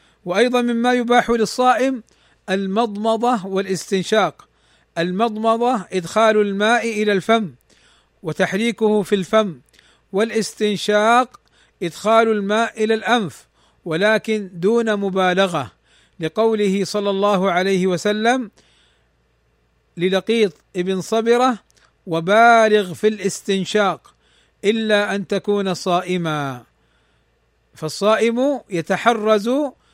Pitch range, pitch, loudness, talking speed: 185-225 Hz, 205 Hz, -18 LUFS, 80 wpm